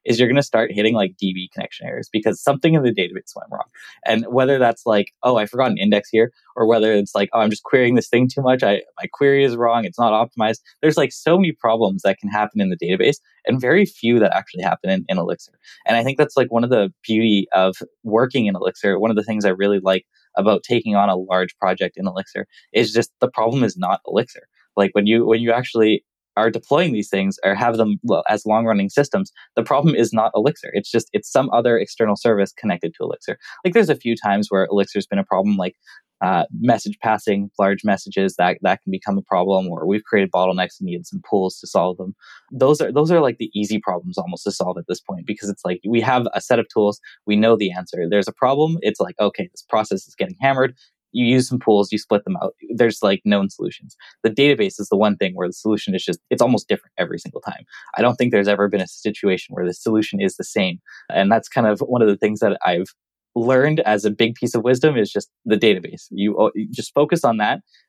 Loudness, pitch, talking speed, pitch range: -19 LUFS, 110 Hz, 245 wpm, 100-130 Hz